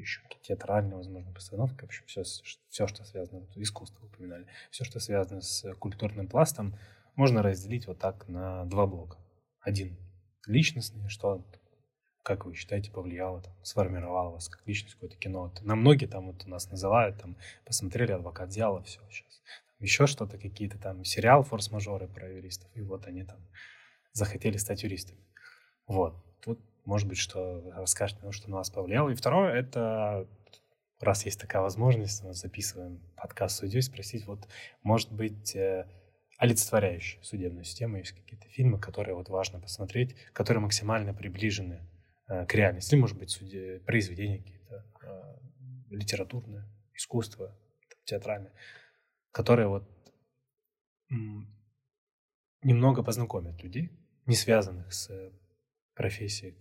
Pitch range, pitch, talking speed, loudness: 95-115 Hz, 100 Hz, 130 wpm, -31 LUFS